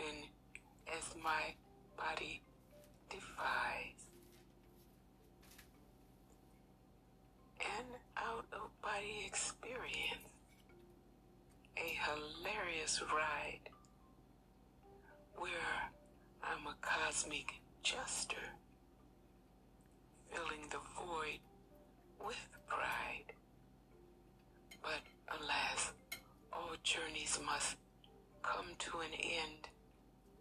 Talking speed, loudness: 60 wpm, -43 LUFS